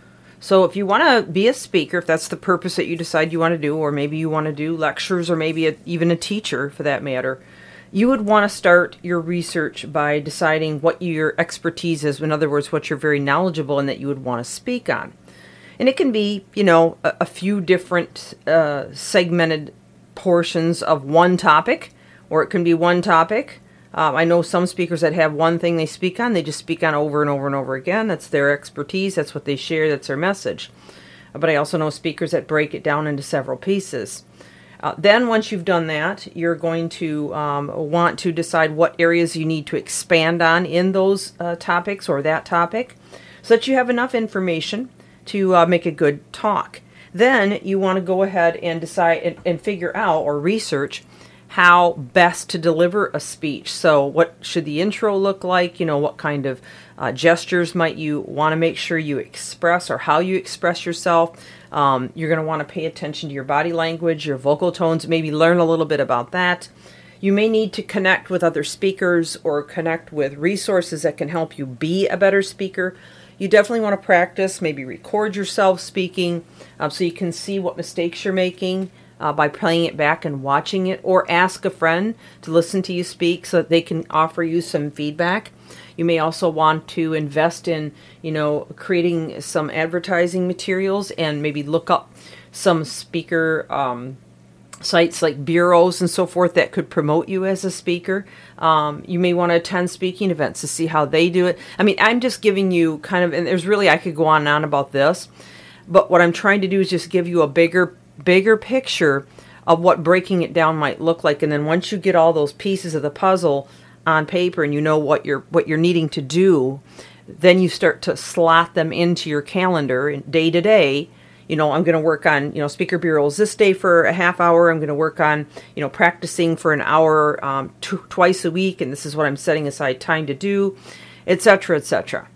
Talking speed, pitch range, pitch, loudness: 210 wpm, 155-180 Hz, 170 Hz, -19 LUFS